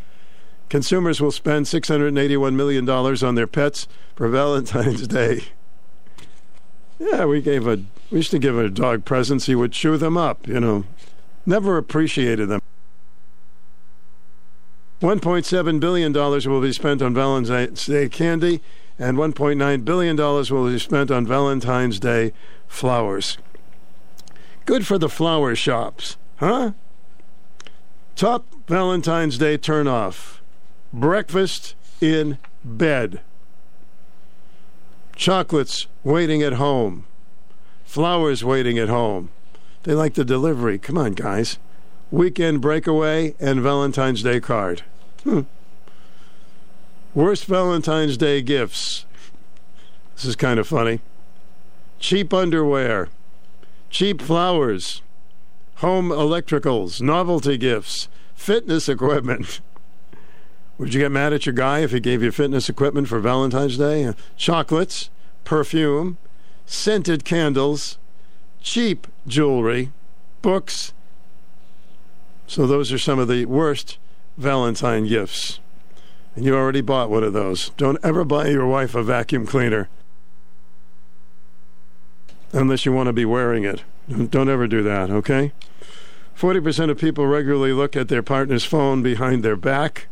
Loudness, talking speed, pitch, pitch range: -20 LUFS, 125 wpm, 140 Hz, 120-160 Hz